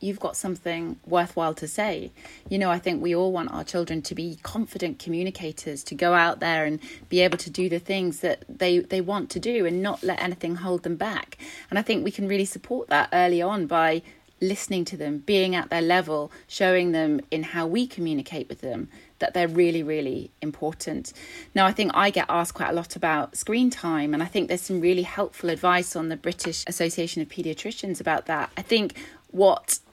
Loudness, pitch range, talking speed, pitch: -25 LUFS, 165-195 Hz, 210 wpm, 175 Hz